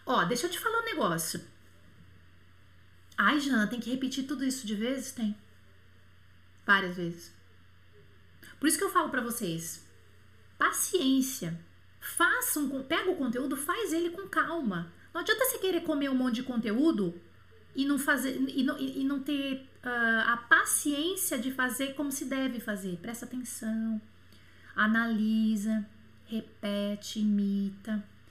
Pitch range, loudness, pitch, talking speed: 180-285 Hz, -30 LUFS, 235 Hz, 140 wpm